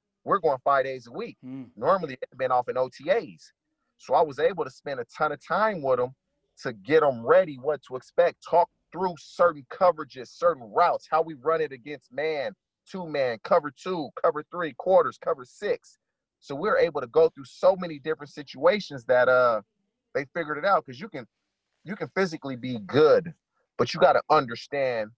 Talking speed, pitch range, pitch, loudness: 190 wpm, 135-185 Hz, 155 Hz, -26 LUFS